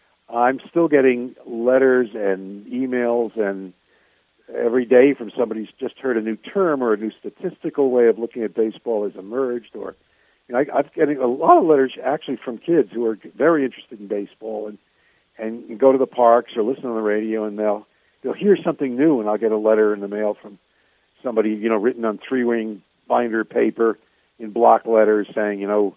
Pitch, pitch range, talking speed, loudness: 115 Hz, 105-125 Hz, 210 wpm, -20 LUFS